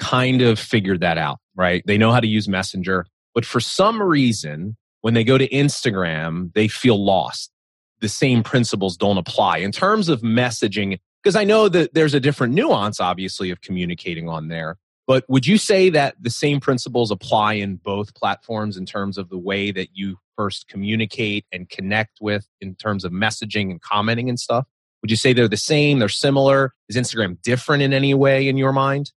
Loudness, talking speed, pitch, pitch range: -19 LUFS, 195 wpm, 110 Hz, 95-130 Hz